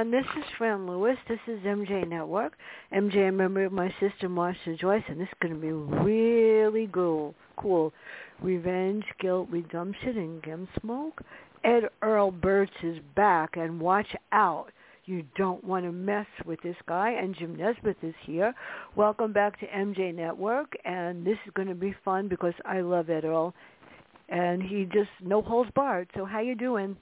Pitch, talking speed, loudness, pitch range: 195 Hz, 175 wpm, -29 LUFS, 175-210 Hz